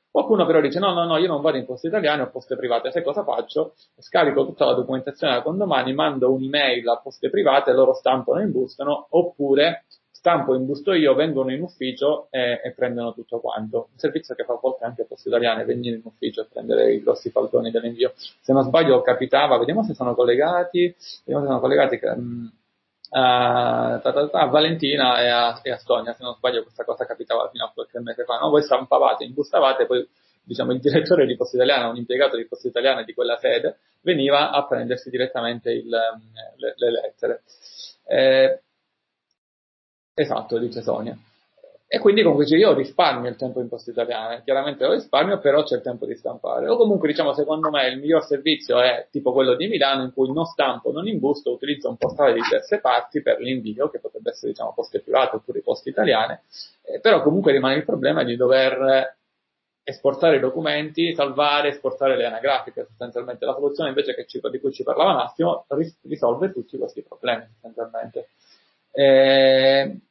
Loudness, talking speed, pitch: -21 LUFS, 185 wpm, 145 Hz